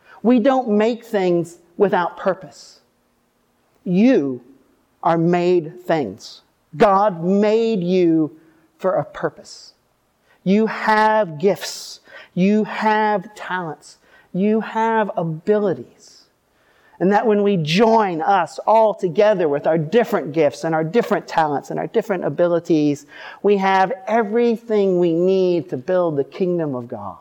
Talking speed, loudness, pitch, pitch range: 125 wpm, -18 LUFS, 190 Hz, 165-215 Hz